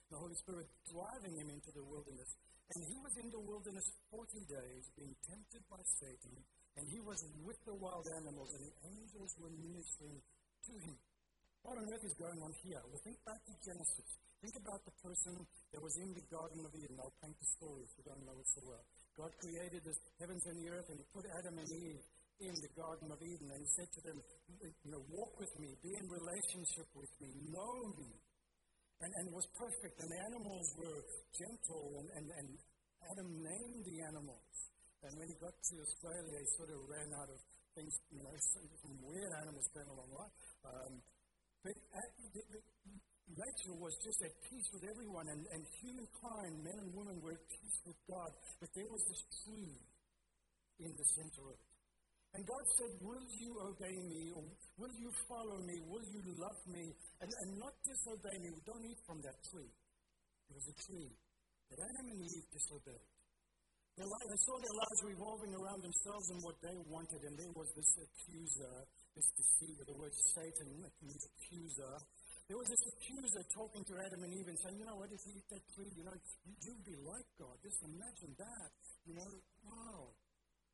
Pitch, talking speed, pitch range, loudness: 170 Hz, 190 wpm, 155-200 Hz, -45 LUFS